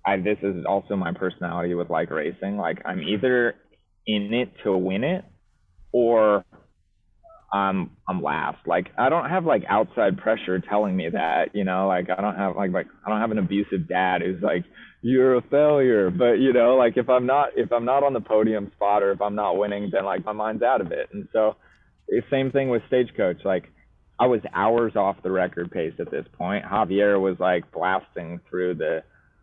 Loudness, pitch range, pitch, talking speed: -23 LUFS, 95-120 Hz, 105 Hz, 205 wpm